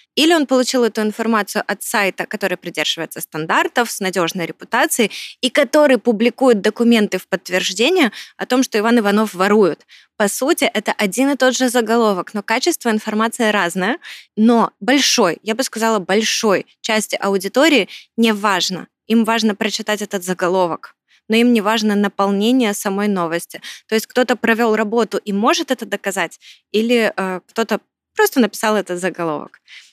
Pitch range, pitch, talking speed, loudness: 195-240 Hz, 220 Hz, 150 wpm, -17 LUFS